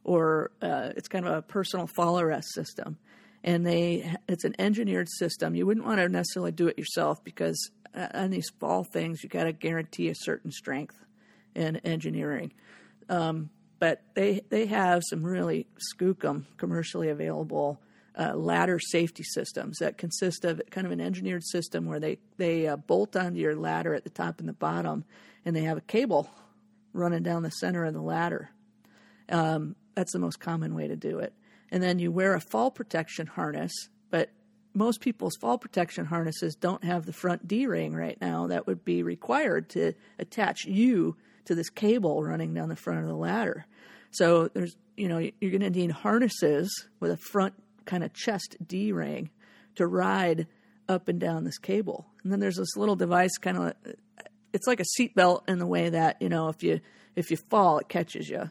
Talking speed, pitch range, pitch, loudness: 190 wpm, 160-200 Hz, 175 Hz, -29 LUFS